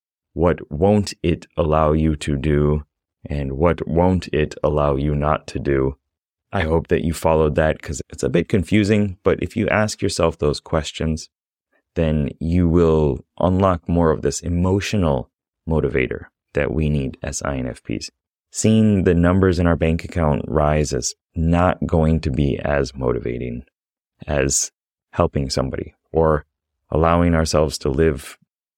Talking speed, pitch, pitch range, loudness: 150 wpm, 80 Hz, 75-85 Hz, -20 LUFS